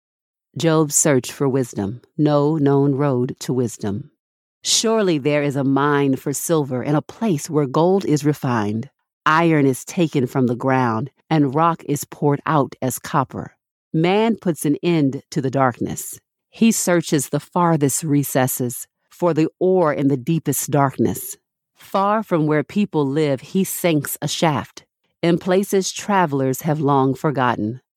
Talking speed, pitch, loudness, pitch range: 150 wpm, 145 Hz, -19 LUFS, 135-165 Hz